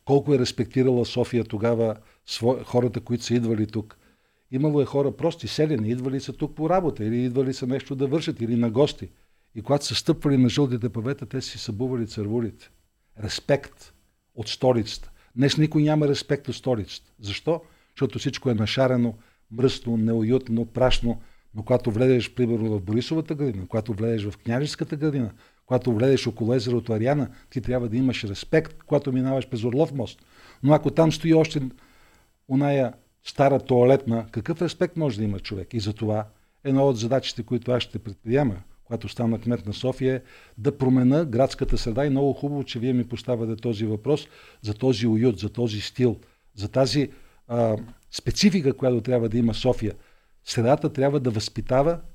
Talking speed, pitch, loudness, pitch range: 170 wpm, 125 Hz, -24 LUFS, 115-140 Hz